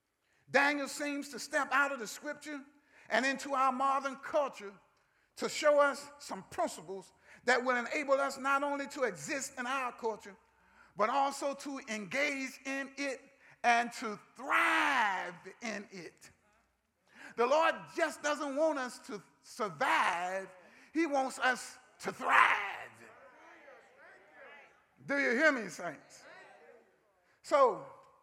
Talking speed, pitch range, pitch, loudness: 125 wpm, 240-285 Hz, 275 Hz, -33 LUFS